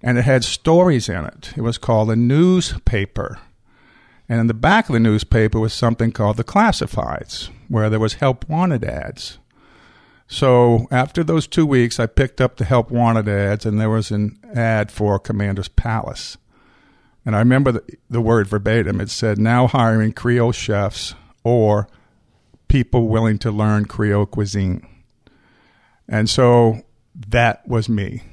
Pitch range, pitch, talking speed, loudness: 105-125 Hz, 115 Hz, 155 wpm, -18 LUFS